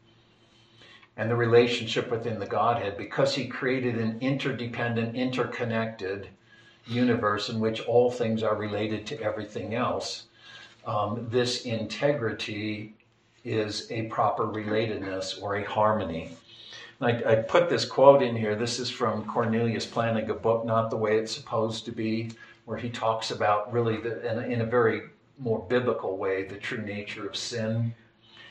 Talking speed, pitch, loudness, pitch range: 155 wpm, 115 Hz, -27 LUFS, 110-120 Hz